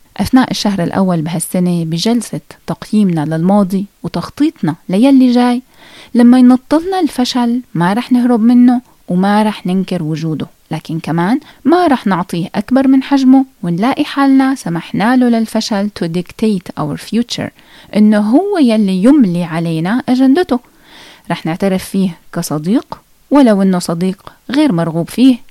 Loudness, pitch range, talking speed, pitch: -13 LUFS, 180-260 Hz, 125 wpm, 220 Hz